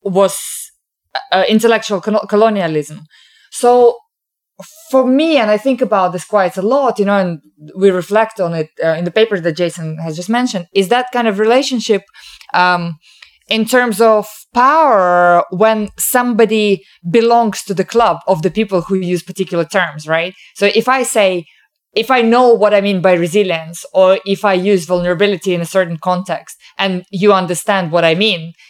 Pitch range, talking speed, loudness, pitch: 180-225 Hz, 175 wpm, -13 LUFS, 195 Hz